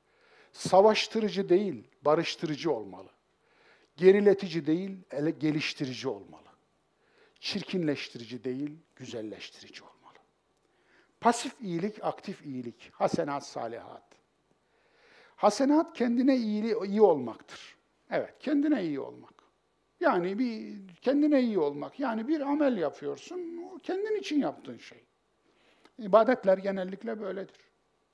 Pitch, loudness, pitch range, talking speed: 215 Hz, -29 LUFS, 175-295 Hz, 95 wpm